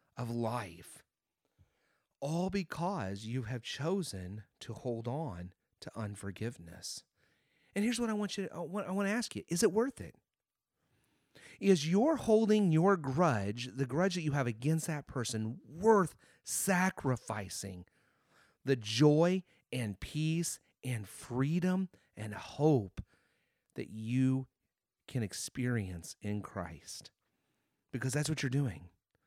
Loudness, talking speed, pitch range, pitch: -34 LUFS, 120 wpm, 110-175 Hz, 135 Hz